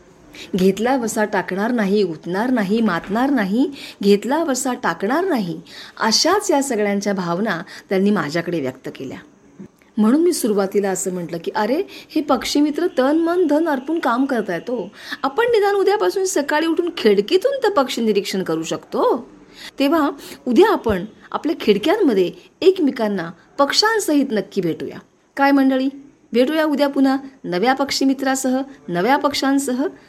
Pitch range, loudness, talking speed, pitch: 205-305 Hz, -19 LUFS, 135 wpm, 265 Hz